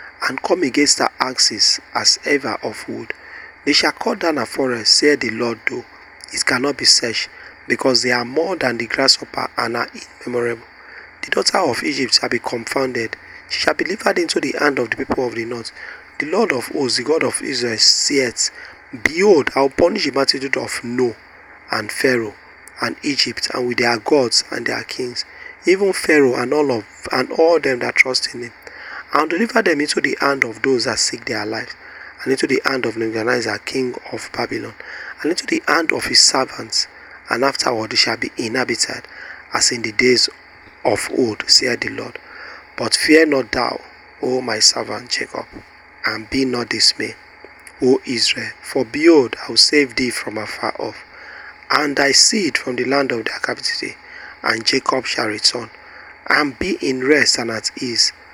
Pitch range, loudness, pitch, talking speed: 120-140 Hz, -17 LUFS, 125 Hz, 185 wpm